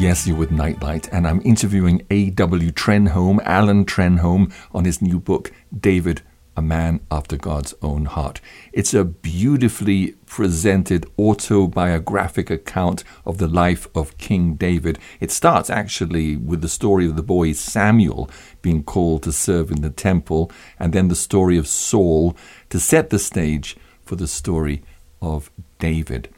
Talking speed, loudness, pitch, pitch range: 150 wpm, -19 LUFS, 85 Hz, 80-95 Hz